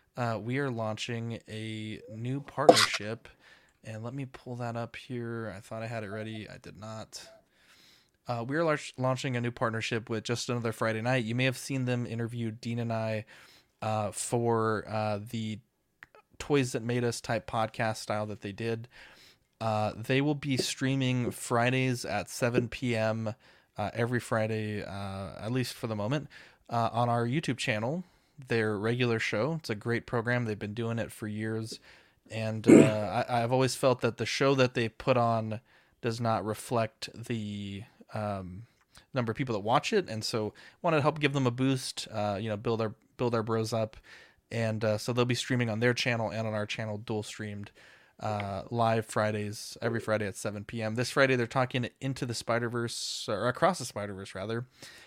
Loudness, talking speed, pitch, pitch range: -31 LUFS, 185 wpm, 115 Hz, 110-125 Hz